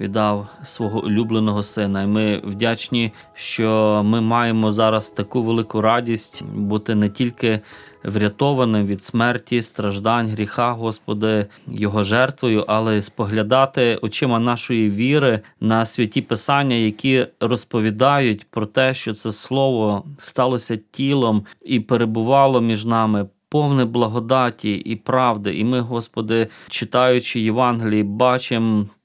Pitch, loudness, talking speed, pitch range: 115 Hz, -19 LUFS, 120 wpm, 105-120 Hz